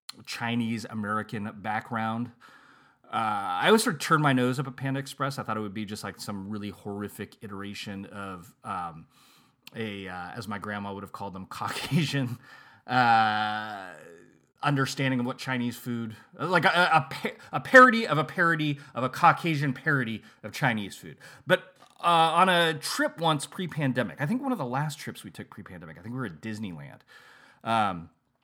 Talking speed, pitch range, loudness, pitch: 175 wpm, 105-150 Hz, -27 LUFS, 120 Hz